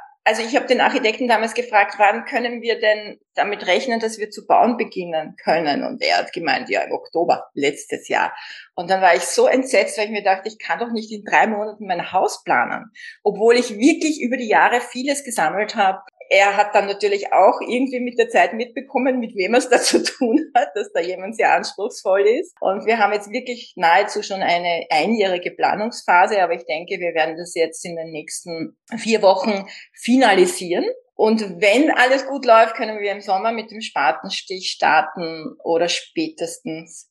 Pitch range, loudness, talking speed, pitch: 190-250 Hz, -19 LUFS, 190 wpm, 215 Hz